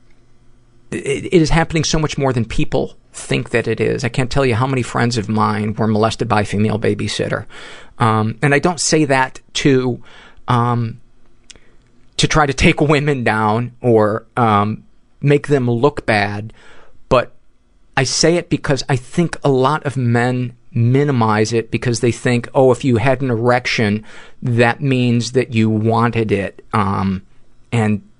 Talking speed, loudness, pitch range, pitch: 165 wpm, -16 LUFS, 110-135 Hz, 120 Hz